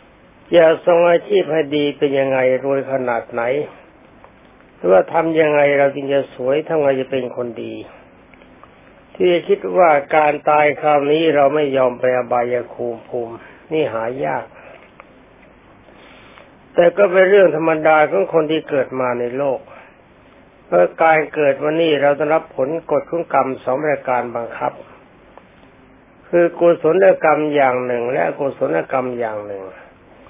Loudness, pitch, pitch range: -16 LUFS, 145 Hz, 130-160 Hz